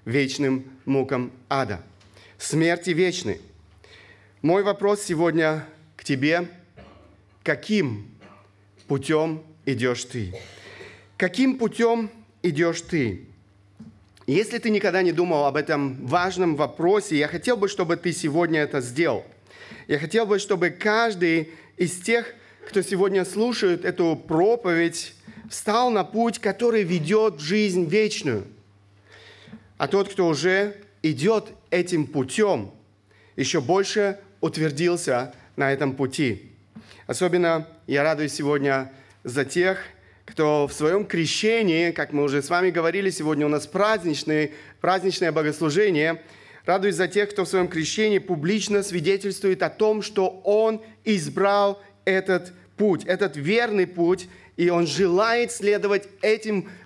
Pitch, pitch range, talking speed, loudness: 170 Hz, 140-200 Hz, 120 wpm, -23 LUFS